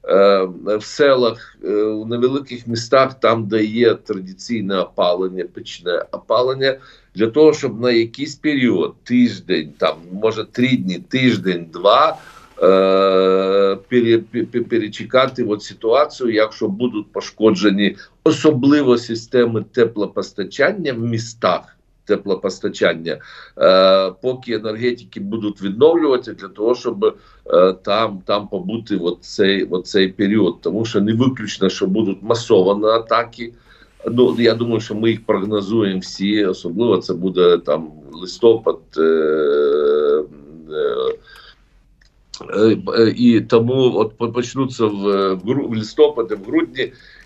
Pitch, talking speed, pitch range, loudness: 115 Hz, 110 wpm, 105-135 Hz, -17 LUFS